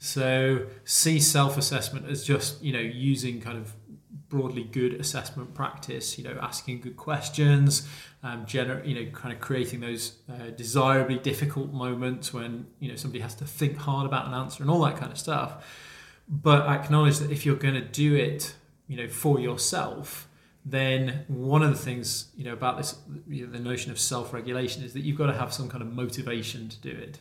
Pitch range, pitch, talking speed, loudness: 125-145 Hz, 135 Hz, 195 wpm, -27 LUFS